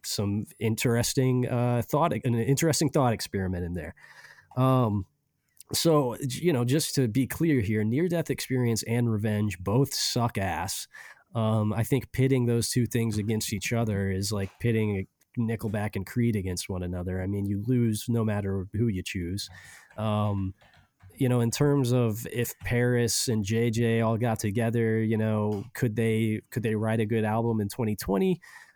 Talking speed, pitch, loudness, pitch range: 170 wpm, 115 Hz, -27 LUFS, 105-125 Hz